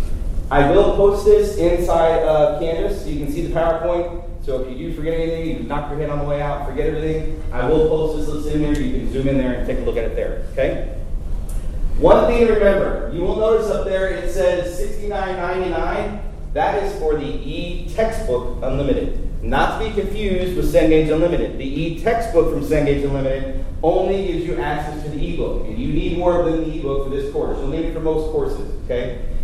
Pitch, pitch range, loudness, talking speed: 165 Hz, 150-190 Hz, -20 LUFS, 210 wpm